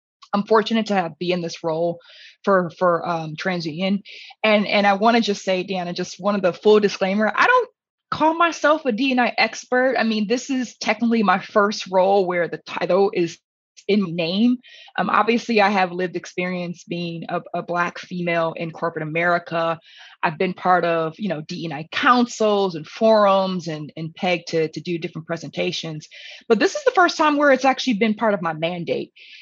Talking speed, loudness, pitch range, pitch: 190 wpm, -20 LUFS, 170-225 Hz, 190 Hz